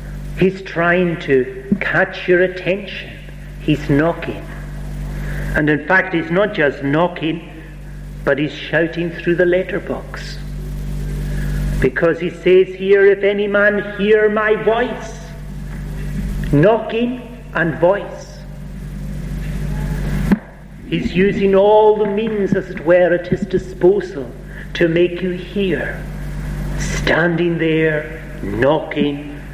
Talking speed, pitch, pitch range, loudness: 105 wpm, 170 Hz, 155-190 Hz, -17 LUFS